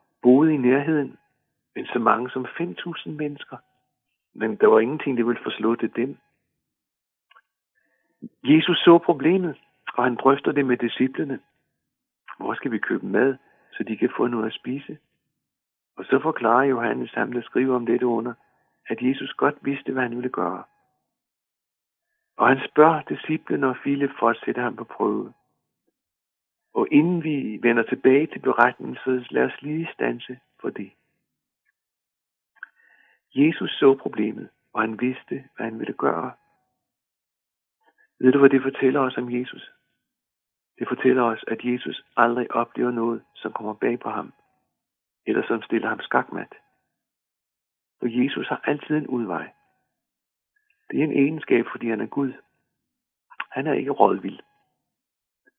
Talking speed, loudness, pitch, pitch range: 150 wpm, -23 LUFS, 130 Hz, 120-150 Hz